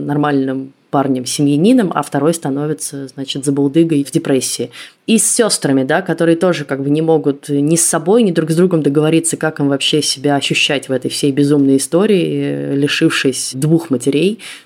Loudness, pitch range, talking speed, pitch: -14 LUFS, 140-165 Hz, 170 wpm, 145 Hz